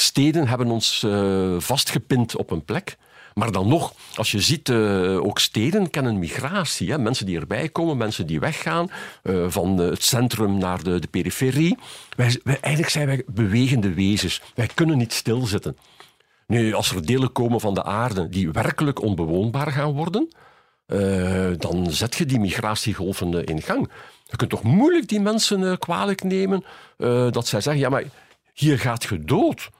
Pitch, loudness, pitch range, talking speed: 120 Hz, -22 LUFS, 100-150 Hz, 175 wpm